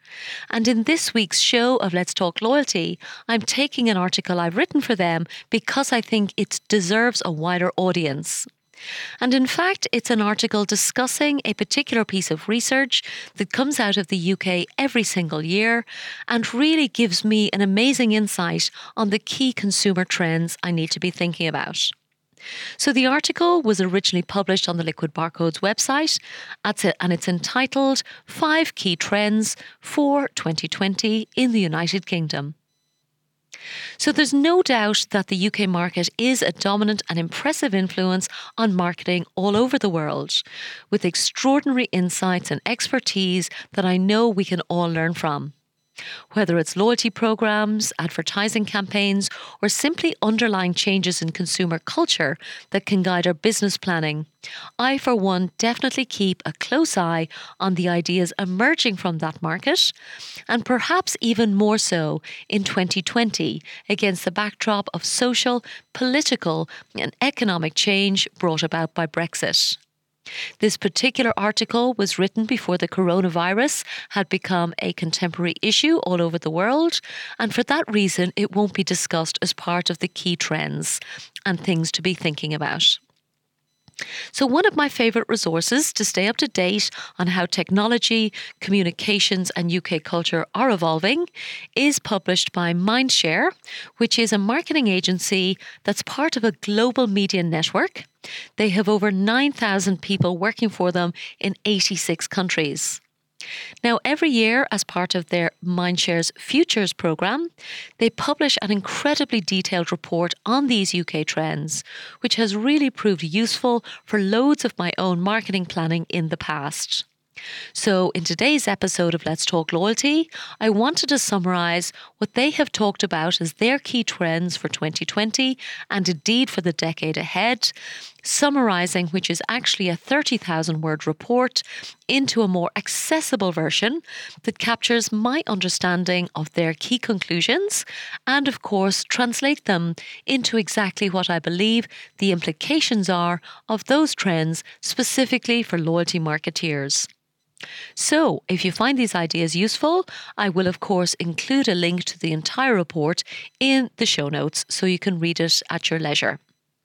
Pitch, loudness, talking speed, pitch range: 200 Hz, -21 LUFS, 150 wpm, 175-235 Hz